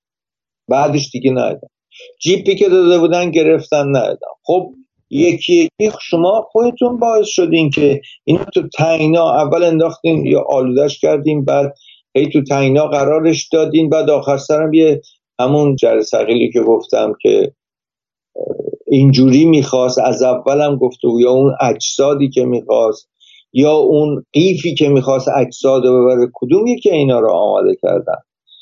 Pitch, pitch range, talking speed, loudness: 155 Hz, 140-215 Hz, 135 wpm, -13 LUFS